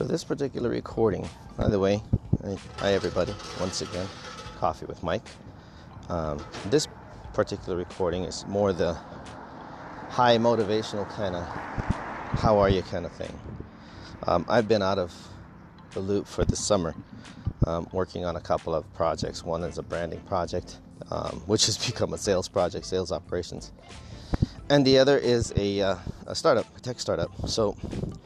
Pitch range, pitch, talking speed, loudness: 90-115 Hz, 100 Hz, 155 wpm, -27 LUFS